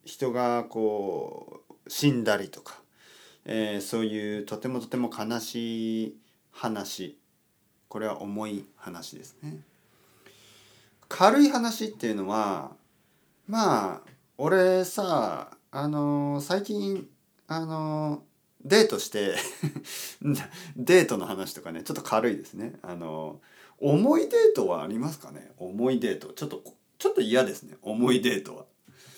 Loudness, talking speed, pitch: -27 LUFS, 230 characters per minute, 125 Hz